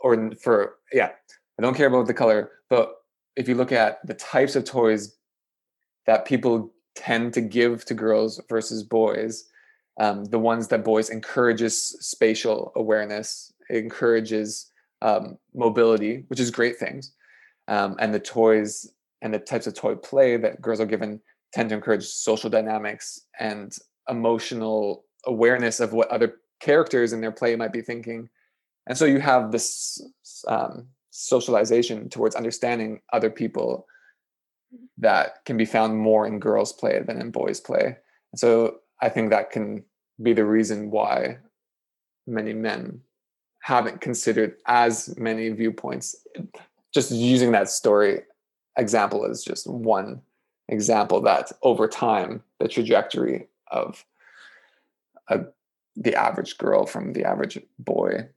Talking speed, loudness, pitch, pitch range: 140 wpm, -23 LUFS, 115 Hz, 110-120 Hz